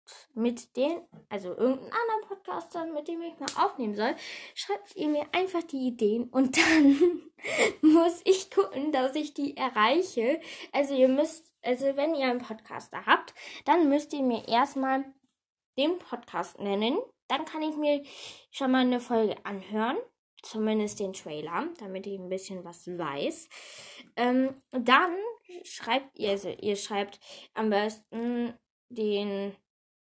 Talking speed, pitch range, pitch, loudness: 145 wpm, 220-310 Hz, 265 Hz, -28 LUFS